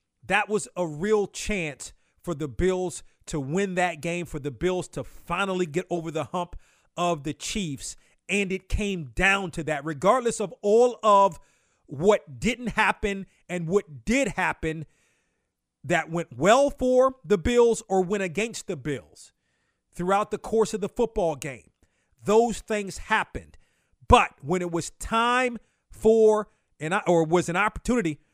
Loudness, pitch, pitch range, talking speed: -25 LUFS, 185 Hz, 165-210 Hz, 155 wpm